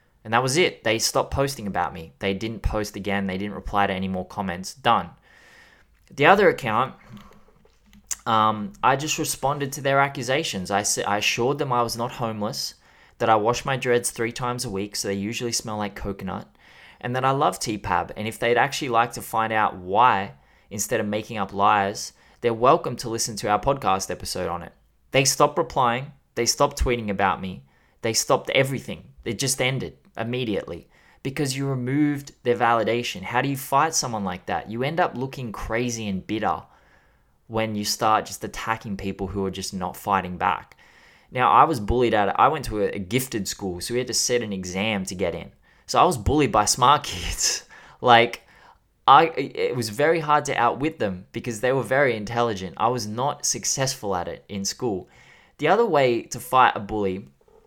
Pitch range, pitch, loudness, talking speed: 100-135 Hz, 115 Hz, -23 LUFS, 195 wpm